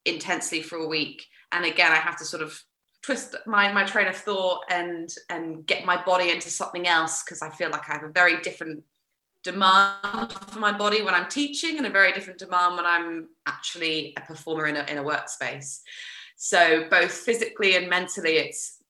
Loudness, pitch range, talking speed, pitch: -24 LUFS, 160-195 Hz, 195 wpm, 175 Hz